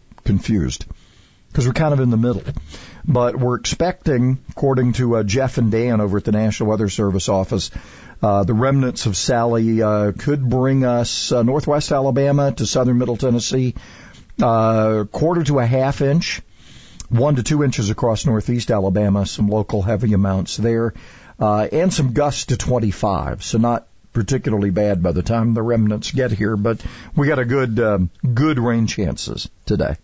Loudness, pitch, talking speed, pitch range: -18 LUFS, 115 Hz, 170 wpm, 105-130 Hz